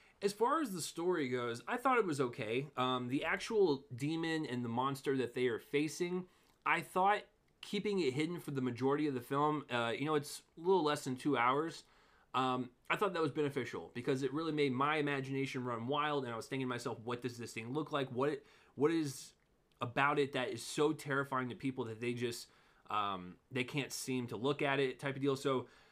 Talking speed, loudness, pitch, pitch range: 220 wpm, -37 LUFS, 140 Hz, 125-155 Hz